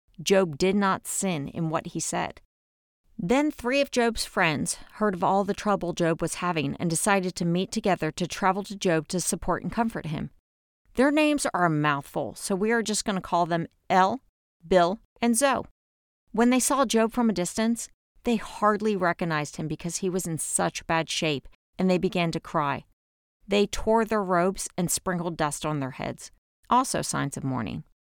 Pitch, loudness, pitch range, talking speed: 180 Hz, -26 LUFS, 165-210 Hz, 190 wpm